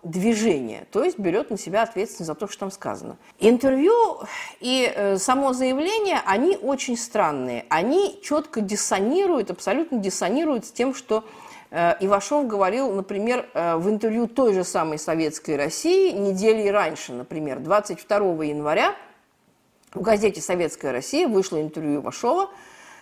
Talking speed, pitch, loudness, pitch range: 130 wpm, 210 Hz, -23 LUFS, 180-260 Hz